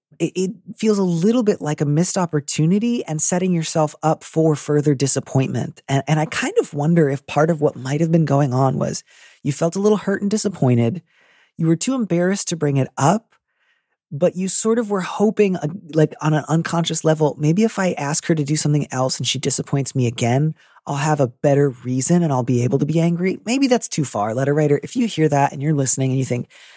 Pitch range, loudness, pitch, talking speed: 140-185 Hz, -19 LUFS, 155 Hz, 225 wpm